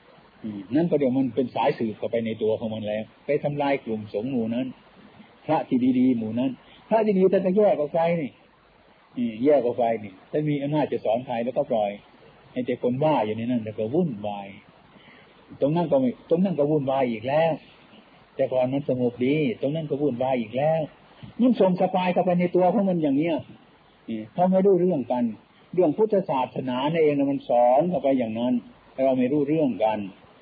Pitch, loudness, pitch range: 140 Hz, -24 LUFS, 120-180 Hz